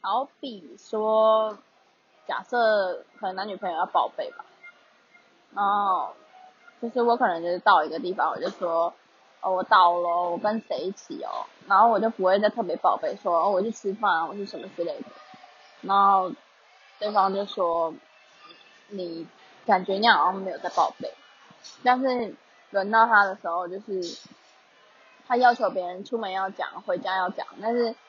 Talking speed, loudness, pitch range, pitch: 230 characters per minute, -25 LUFS, 185-240 Hz, 205 Hz